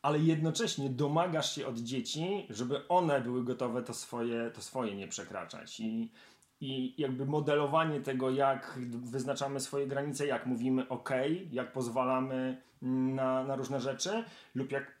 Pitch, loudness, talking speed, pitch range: 135 Hz, -34 LUFS, 150 wpm, 130-150 Hz